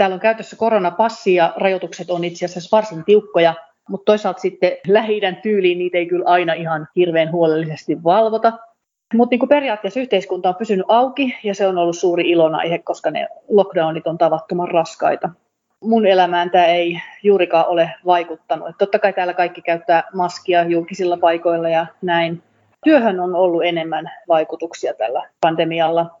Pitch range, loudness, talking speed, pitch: 170-205 Hz, -17 LUFS, 155 wpm, 180 Hz